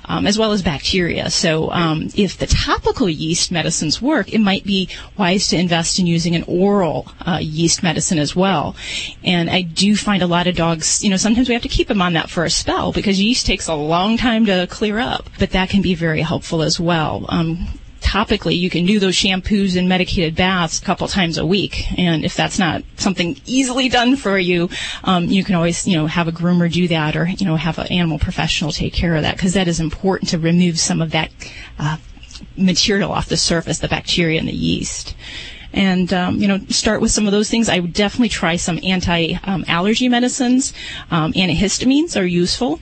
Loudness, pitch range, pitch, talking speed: -17 LUFS, 170-205 Hz, 180 Hz, 215 wpm